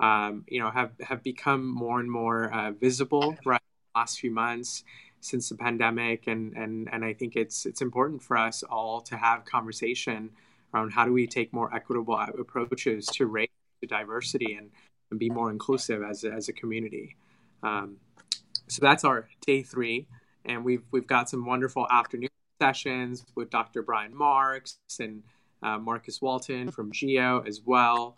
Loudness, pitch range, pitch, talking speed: -28 LUFS, 110-130 Hz, 120 Hz, 170 wpm